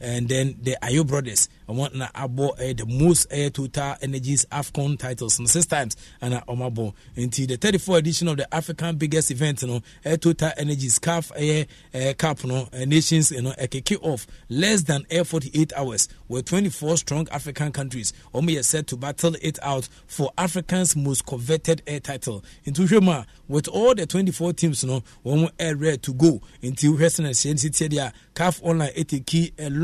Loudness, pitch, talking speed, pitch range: -23 LUFS, 145 Hz, 185 wpm, 130-160 Hz